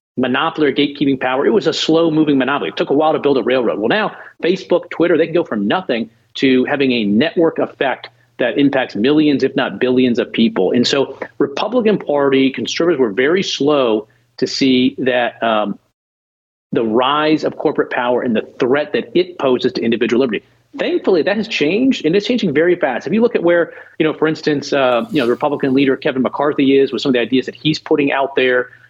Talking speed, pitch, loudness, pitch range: 210 wpm, 145 Hz, -16 LUFS, 130-160 Hz